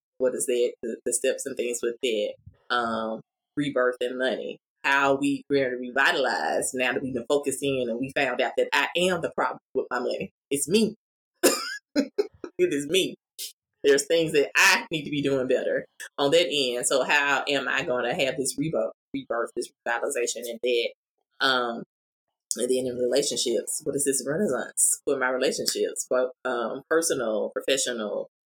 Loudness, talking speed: -25 LUFS, 175 wpm